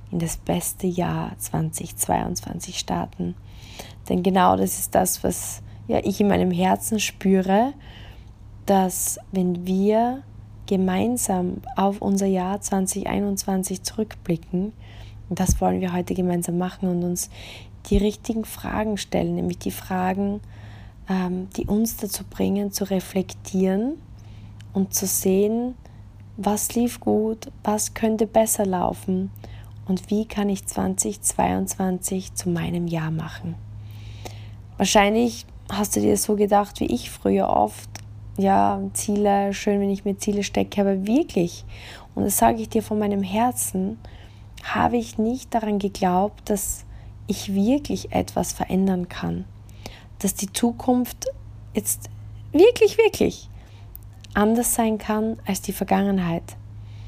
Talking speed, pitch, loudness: 125 wpm, 180 Hz, -23 LUFS